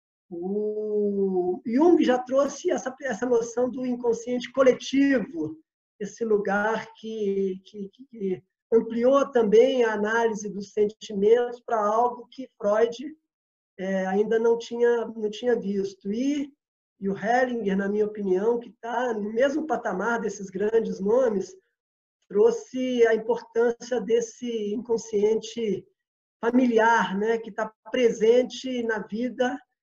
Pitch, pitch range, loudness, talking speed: 230 Hz, 210-245 Hz, -25 LUFS, 120 wpm